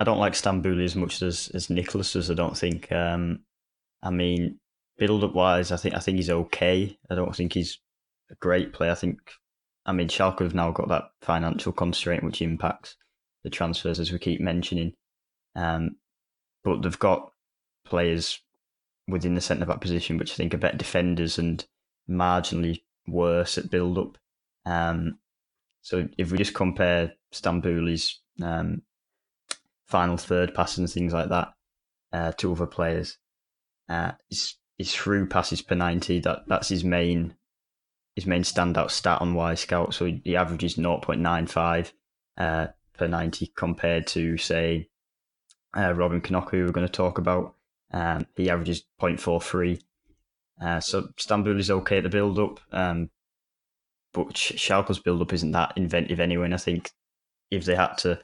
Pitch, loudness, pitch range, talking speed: 85 Hz, -26 LUFS, 85-90 Hz, 170 wpm